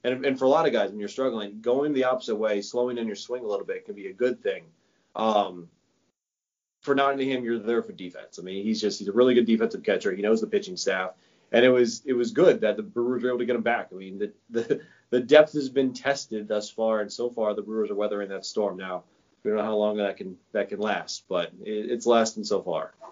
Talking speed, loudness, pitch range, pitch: 255 wpm, -26 LUFS, 105-130 Hz, 115 Hz